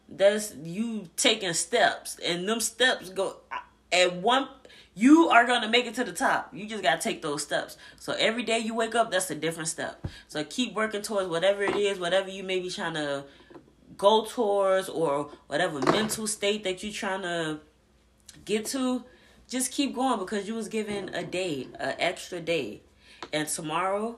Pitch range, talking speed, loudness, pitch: 180-230 Hz, 180 wpm, -27 LUFS, 205 Hz